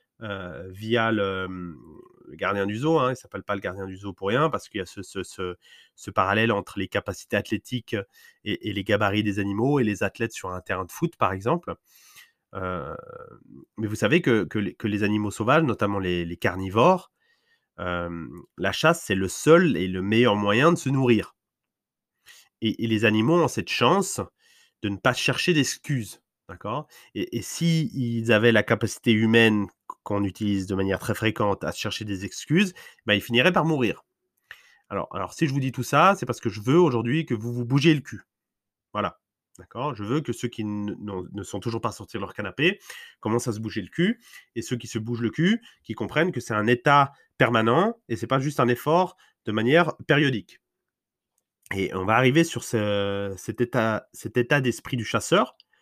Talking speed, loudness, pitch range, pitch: 205 wpm, -24 LUFS, 100-145 Hz, 115 Hz